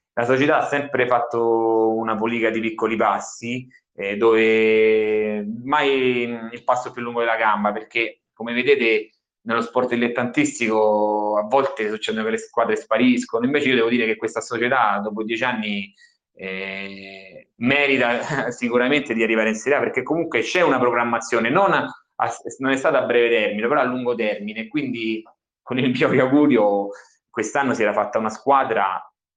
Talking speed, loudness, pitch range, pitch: 160 wpm, -20 LUFS, 110-130 Hz, 115 Hz